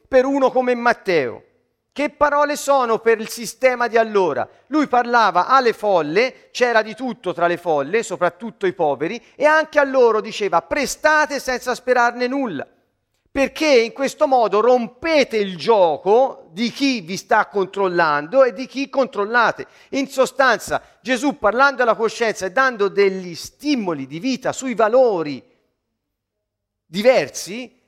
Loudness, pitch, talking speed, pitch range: -18 LUFS, 245 Hz, 140 wpm, 205-270 Hz